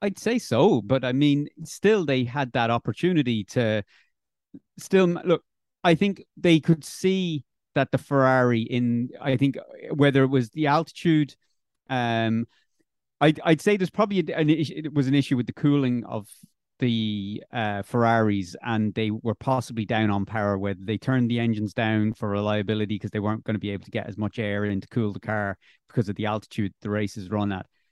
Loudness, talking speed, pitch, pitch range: -25 LUFS, 195 wpm, 120 Hz, 105-145 Hz